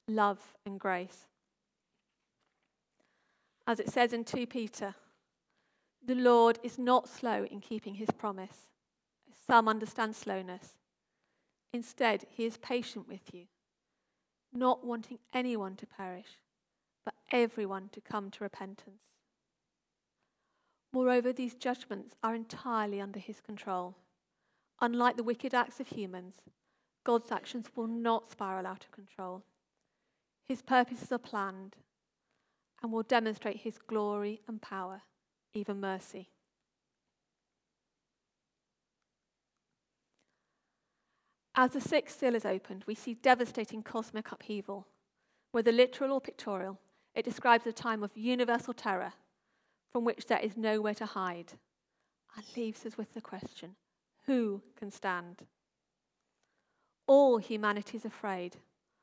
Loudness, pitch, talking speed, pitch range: -33 LUFS, 220 Hz, 115 wpm, 200-240 Hz